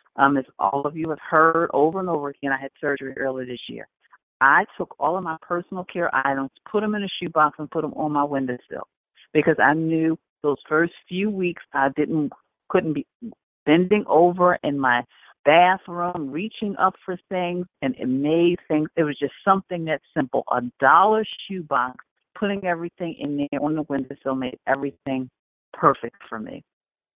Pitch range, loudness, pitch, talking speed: 140-180 Hz, -22 LUFS, 155 Hz, 175 wpm